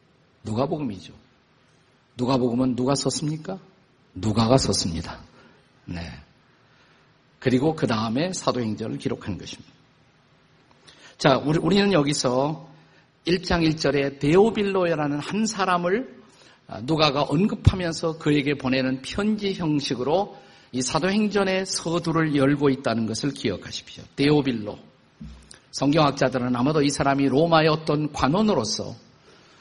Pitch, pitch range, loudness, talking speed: 145 Hz, 130-165 Hz, -23 LUFS, 270 characters per minute